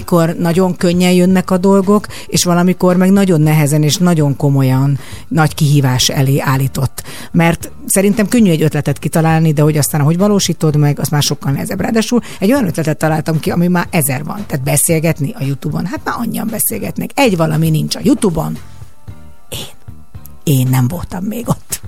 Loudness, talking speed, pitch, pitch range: -13 LUFS, 175 wpm, 160 Hz, 140-185 Hz